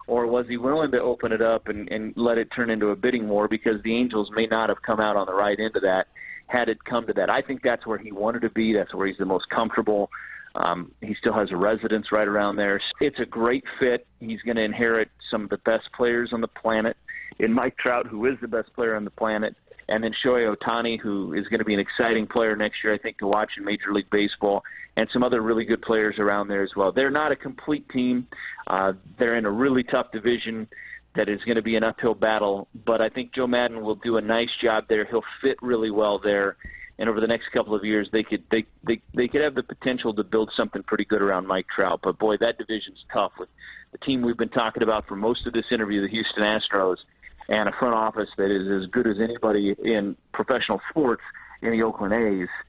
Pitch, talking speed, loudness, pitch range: 110 Hz, 245 wpm, -24 LUFS, 105-120 Hz